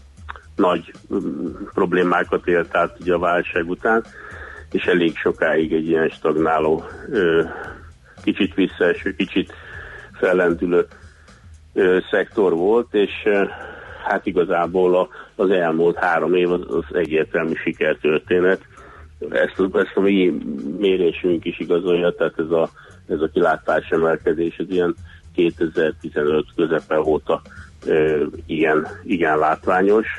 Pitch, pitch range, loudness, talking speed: 85 Hz, 80-90 Hz, -20 LUFS, 105 wpm